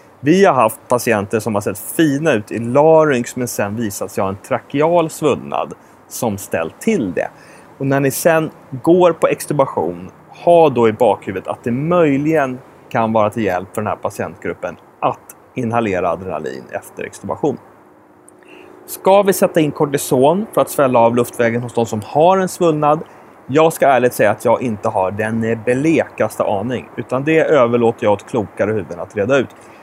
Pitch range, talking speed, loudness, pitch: 115-155 Hz, 175 wpm, -16 LUFS, 125 Hz